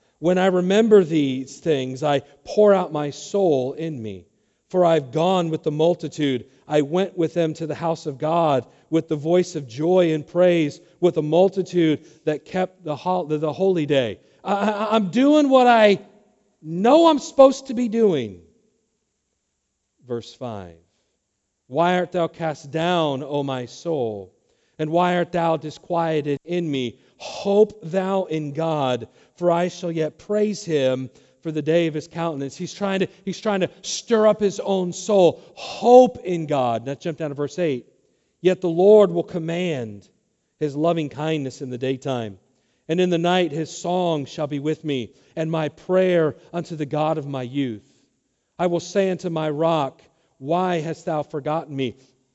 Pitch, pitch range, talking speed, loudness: 165 Hz, 145-180 Hz, 165 wpm, -21 LUFS